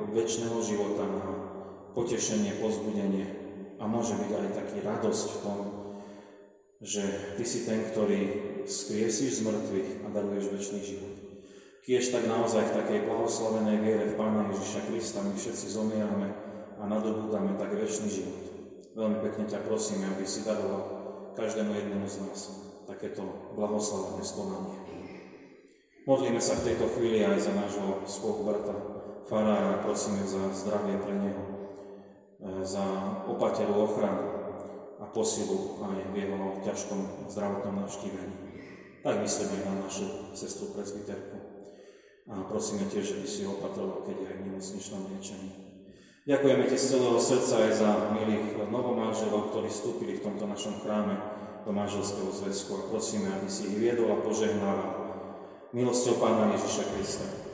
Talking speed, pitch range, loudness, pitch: 140 wpm, 100-110 Hz, -31 LUFS, 105 Hz